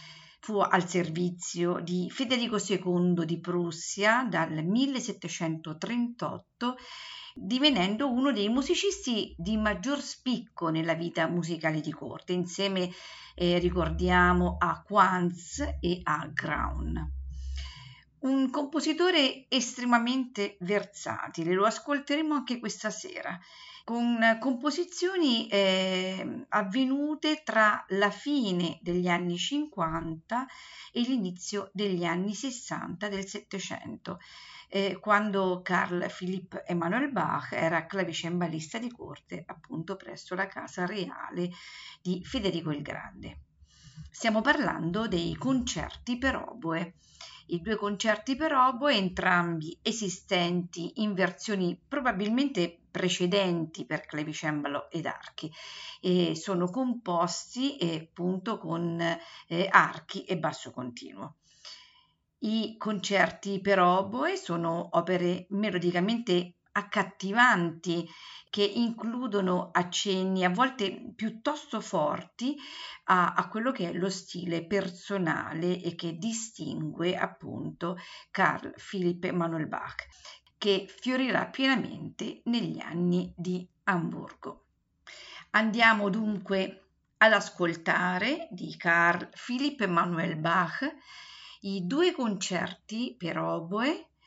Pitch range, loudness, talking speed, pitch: 175-235 Hz, -29 LUFS, 100 wpm, 195 Hz